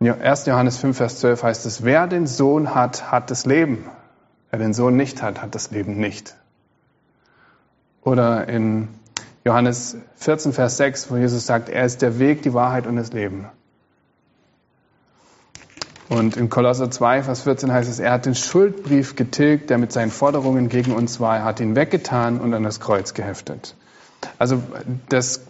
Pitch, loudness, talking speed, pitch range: 125 Hz, -20 LUFS, 170 wpm, 115-130 Hz